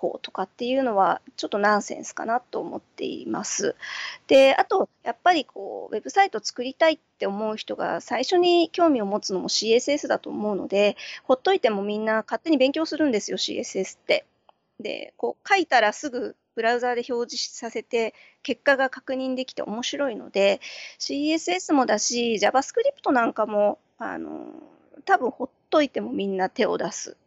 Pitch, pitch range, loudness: 260 Hz, 220-315 Hz, -24 LUFS